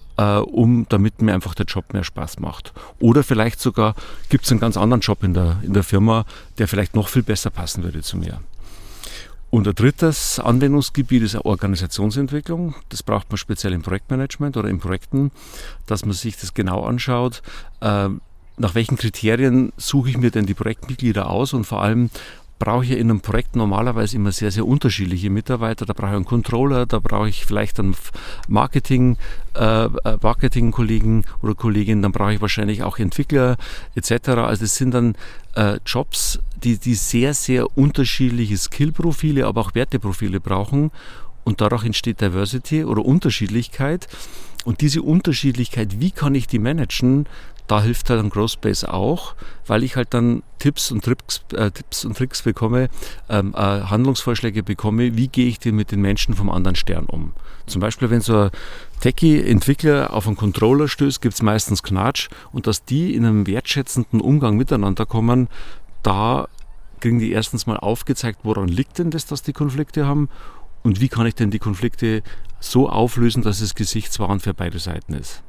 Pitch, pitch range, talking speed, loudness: 110 Hz, 105-125 Hz, 175 wpm, -20 LUFS